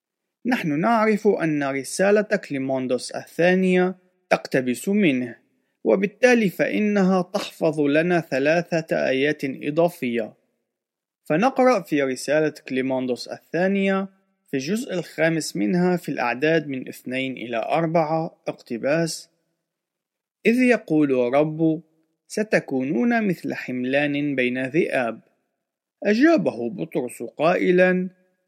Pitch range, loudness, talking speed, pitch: 145-190 Hz, -22 LUFS, 90 wpm, 165 Hz